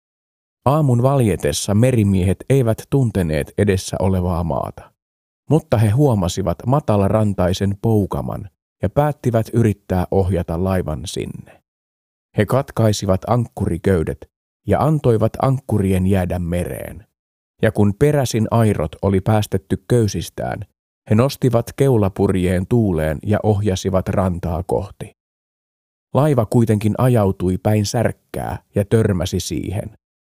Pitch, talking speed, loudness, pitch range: 100 Hz, 100 wpm, -18 LUFS, 90-115 Hz